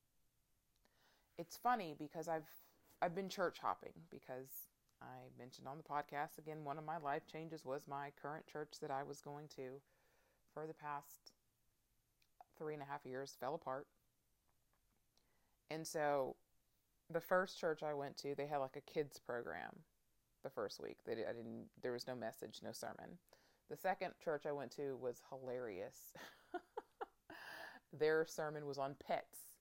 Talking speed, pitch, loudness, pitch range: 160 wpm, 145 Hz, -46 LUFS, 135-160 Hz